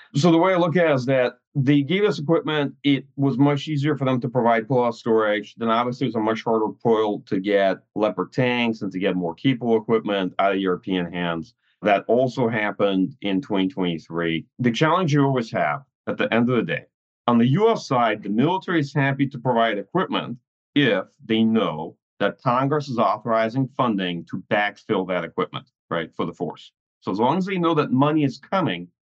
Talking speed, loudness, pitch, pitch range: 205 wpm, -22 LUFS, 120 Hz, 105-140 Hz